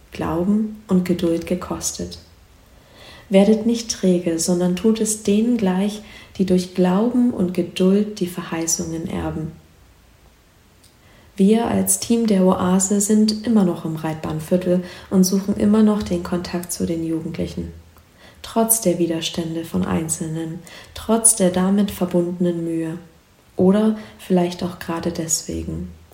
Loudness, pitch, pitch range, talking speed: -20 LUFS, 180 Hz, 165-200 Hz, 125 wpm